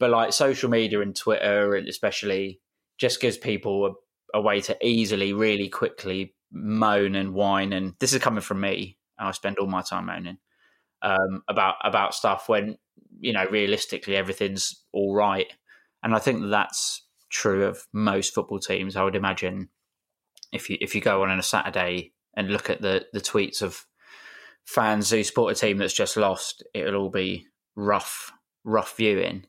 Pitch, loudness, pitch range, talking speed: 100 Hz, -25 LUFS, 95-105 Hz, 175 wpm